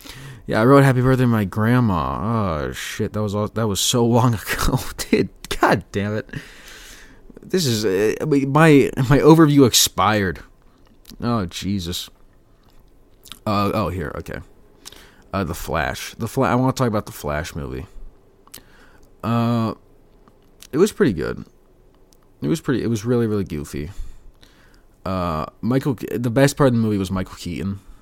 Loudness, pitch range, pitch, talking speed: -19 LUFS, 95-125 Hz, 110 Hz, 155 wpm